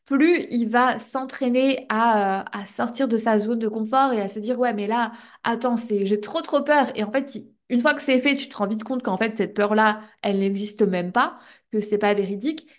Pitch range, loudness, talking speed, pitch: 210-265 Hz, -22 LUFS, 240 wpm, 230 Hz